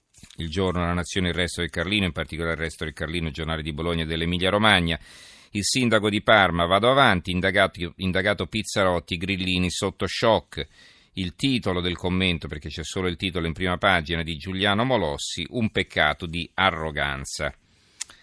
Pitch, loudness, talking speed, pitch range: 90 Hz, -24 LUFS, 170 wpm, 85-95 Hz